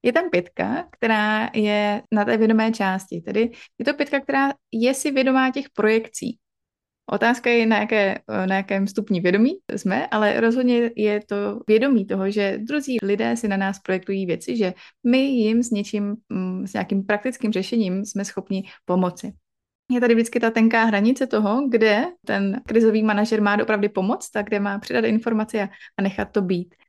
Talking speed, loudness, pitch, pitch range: 170 wpm, -21 LUFS, 215 Hz, 200-235 Hz